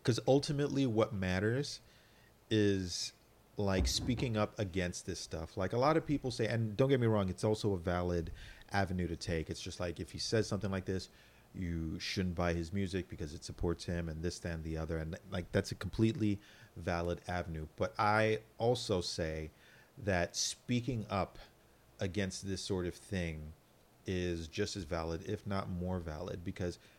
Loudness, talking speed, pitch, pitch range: -36 LUFS, 180 wpm, 95 Hz, 85-110 Hz